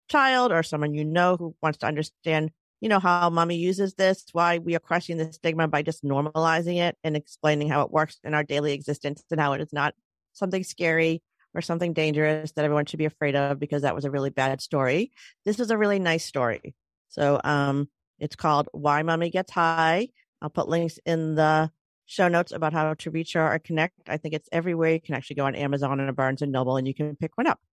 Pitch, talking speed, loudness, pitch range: 160 Hz, 225 wpm, -25 LUFS, 150-170 Hz